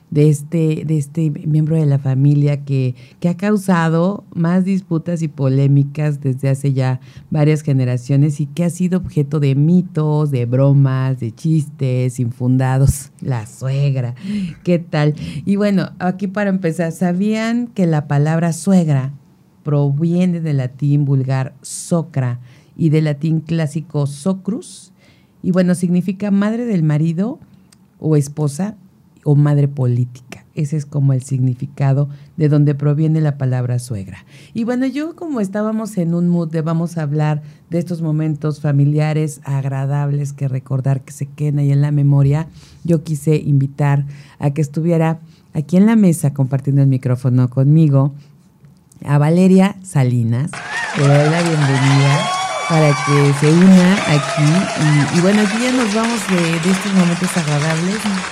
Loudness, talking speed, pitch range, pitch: -16 LUFS, 145 wpm, 140-175 Hz, 150 Hz